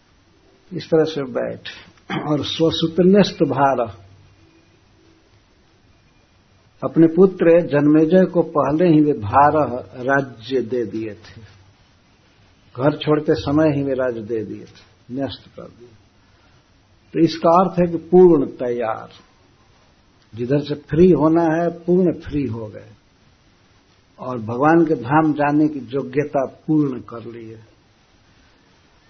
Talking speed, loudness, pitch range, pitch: 120 wpm, -18 LUFS, 110-155 Hz, 135 Hz